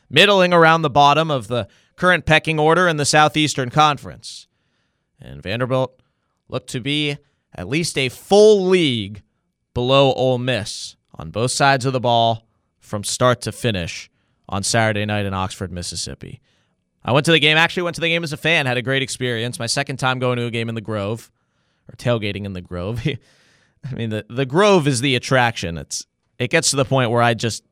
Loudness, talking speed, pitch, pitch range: -18 LUFS, 195 wpm, 130 Hz, 115-150 Hz